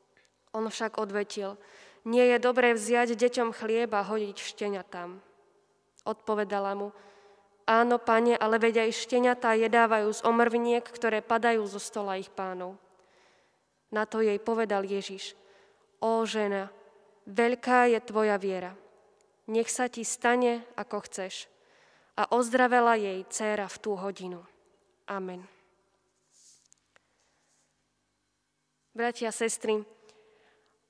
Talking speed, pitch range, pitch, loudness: 105 wpm, 200-230 Hz, 215 Hz, -28 LUFS